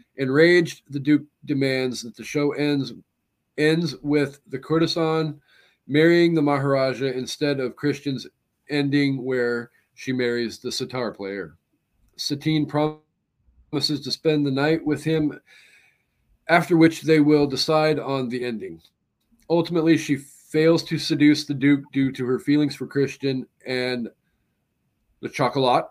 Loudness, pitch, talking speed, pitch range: -22 LUFS, 145 Hz, 130 wpm, 130-155 Hz